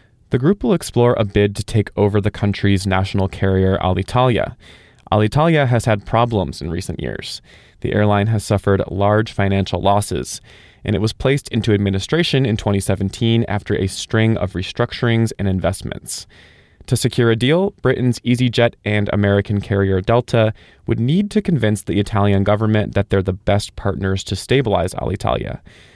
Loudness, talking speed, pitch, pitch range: -18 LUFS, 155 wpm, 105 Hz, 100-120 Hz